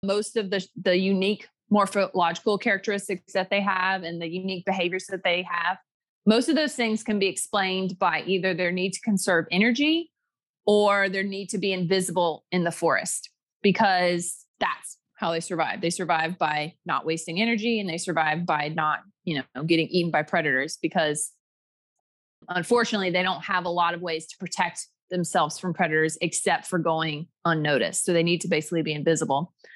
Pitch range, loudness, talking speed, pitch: 165-195 Hz, -25 LUFS, 175 wpm, 180 Hz